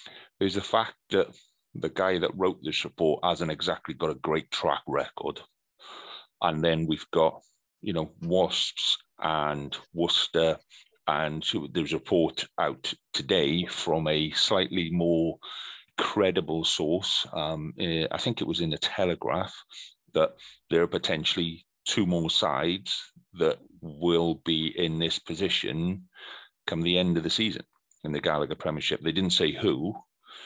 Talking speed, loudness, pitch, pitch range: 145 wpm, -28 LUFS, 80 Hz, 80-85 Hz